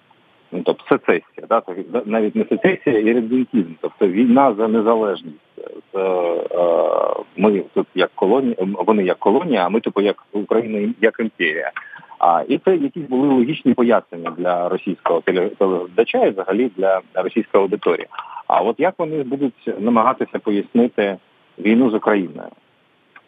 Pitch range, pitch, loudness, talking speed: 100-130 Hz, 115 Hz, -18 LUFS, 130 wpm